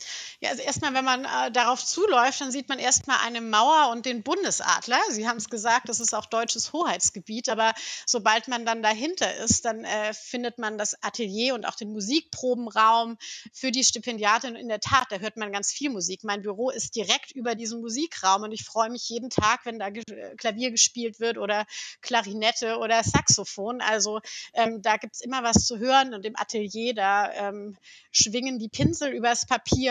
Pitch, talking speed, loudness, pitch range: 230 Hz, 190 wpm, -25 LUFS, 215-250 Hz